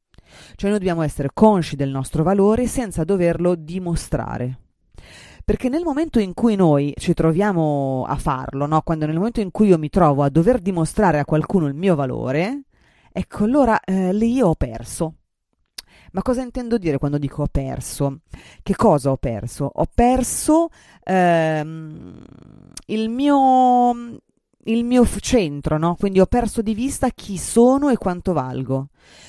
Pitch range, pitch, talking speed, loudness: 145-230 Hz, 180 Hz, 155 wpm, -19 LUFS